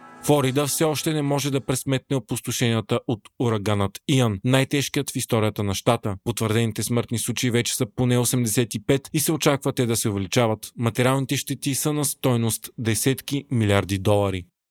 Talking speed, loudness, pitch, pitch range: 155 wpm, -23 LUFS, 125 Hz, 115-140 Hz